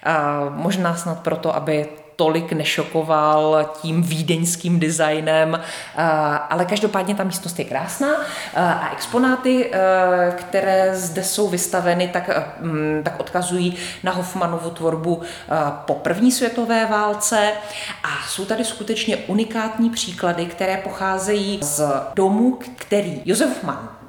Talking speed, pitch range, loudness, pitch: 110 wpm, 160-205 Hz, -20 LUFS, 180 Hz